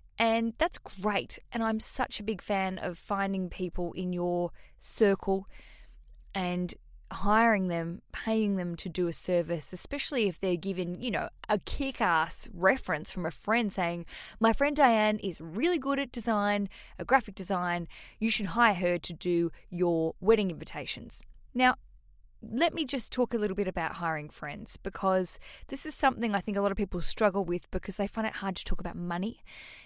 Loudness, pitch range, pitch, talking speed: -30 LUFS, 175-225 Hz, 195 Hz, 180 wpm